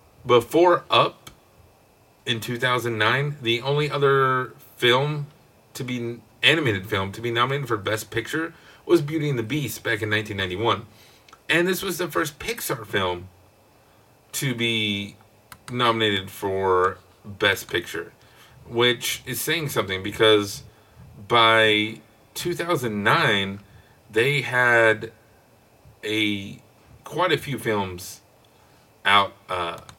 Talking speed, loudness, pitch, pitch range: 120 wpm, -22 LUFS, 115 Hz, 110-135 Hz